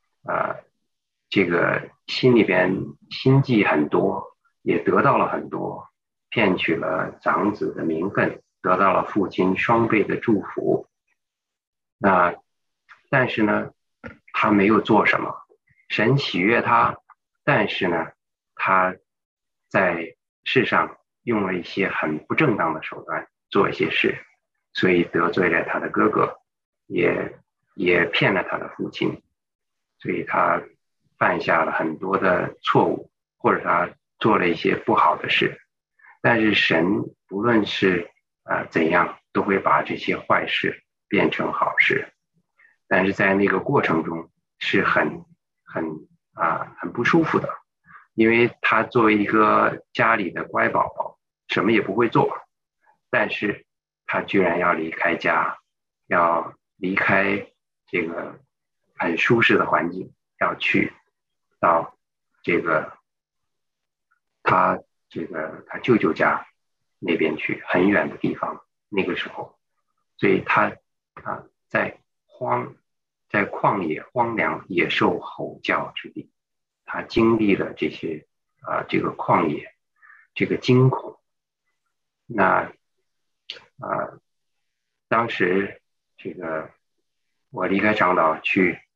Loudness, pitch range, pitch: -21 LUFS, 85-120 Hz, 95 Hz